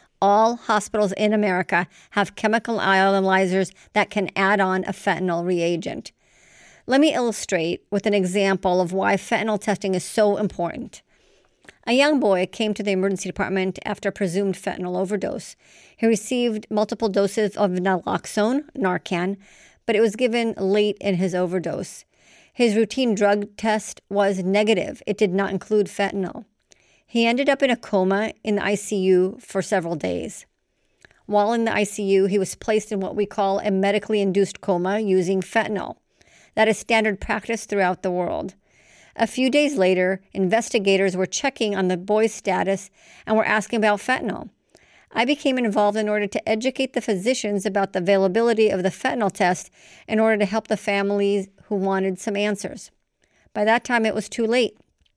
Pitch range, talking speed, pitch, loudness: 190-220 Hz, 165 wpm, 205 Hz, -22 LUFS